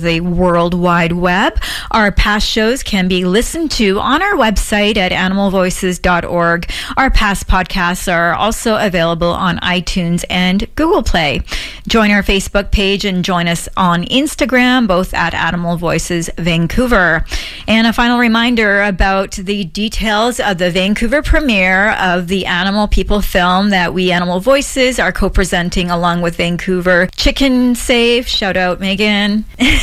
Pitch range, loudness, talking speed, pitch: 180-220 Hz, -13 LUFS, 145 wpm, 195 Hz